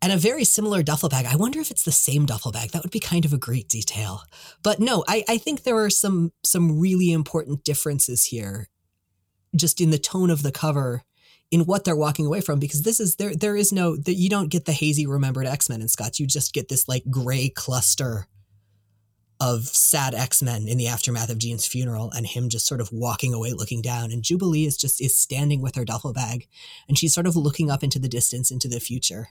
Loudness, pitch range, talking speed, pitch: -22 LUFS, 120-170 Hz, 235 wpm, 140 Hz